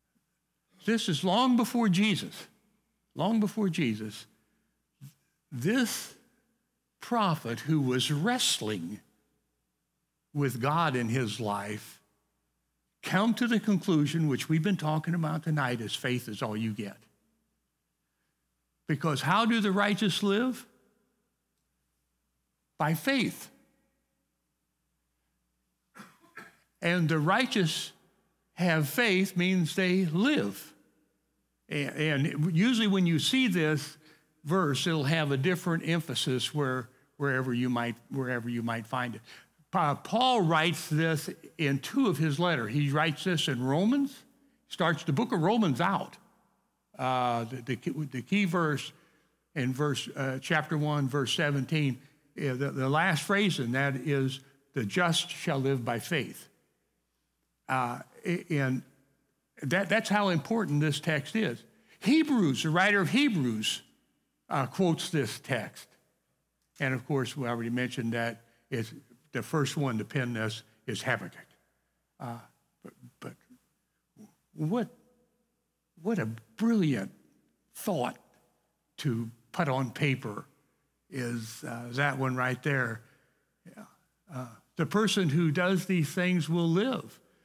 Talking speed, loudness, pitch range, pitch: 125 wpm, -29 LUFS, 130-185 Hz, 155 Hz